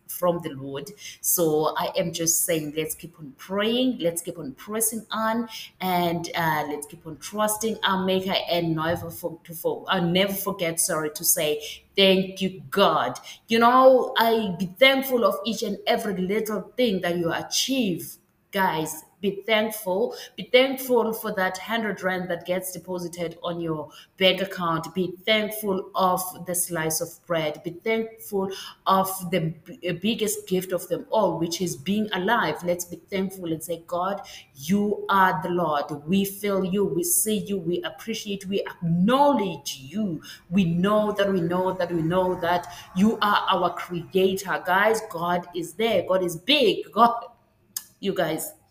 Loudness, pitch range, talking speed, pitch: -24 LUFS, 170-210 Hz, 165 wpm, 185 Hz